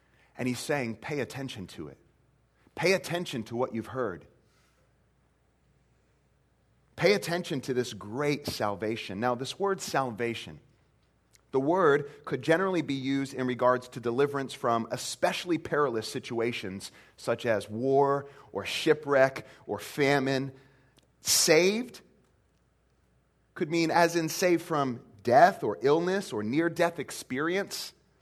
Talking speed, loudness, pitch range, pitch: 125 wpm, -28 LUFS, 120-160 Hz, 135 Hz